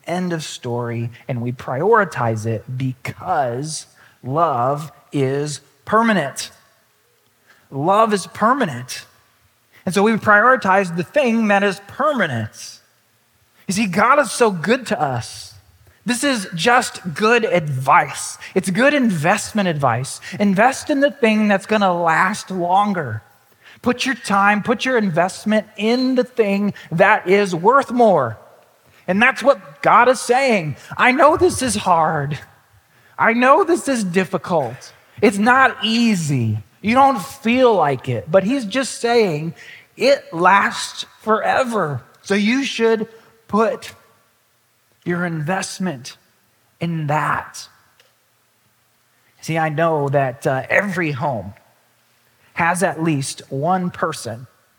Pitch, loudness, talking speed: 180 Hz, -18 LUFS, 125 wpm